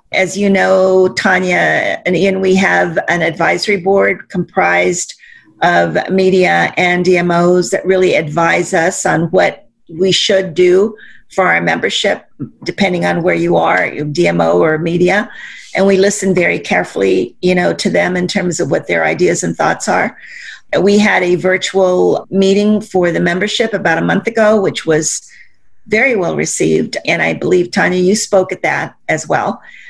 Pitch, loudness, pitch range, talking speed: 185 Hz, -12 LUFS, 175-195 Hz, 165 wpm